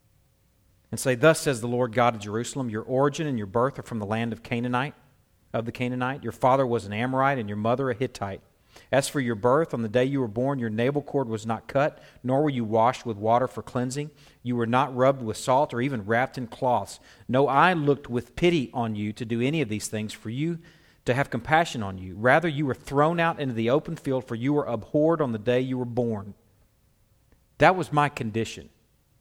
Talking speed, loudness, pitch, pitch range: 230 wpm, -26 LUFS, 125 Hz, 115-140 Hz